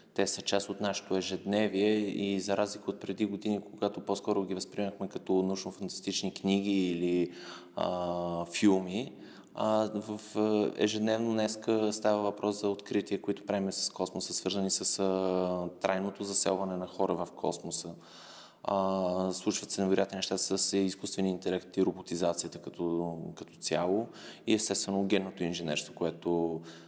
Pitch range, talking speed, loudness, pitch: 95-105 Hz, 135 wpm, -31 LUFS, 95 Hz